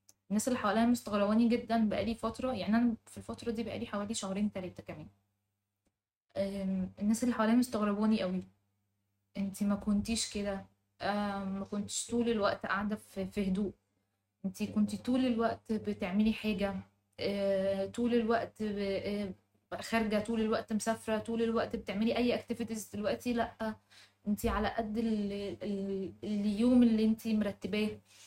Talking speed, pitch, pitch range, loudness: 125 wpm, 210 Hz, 195-225 Hz, -33 LUFS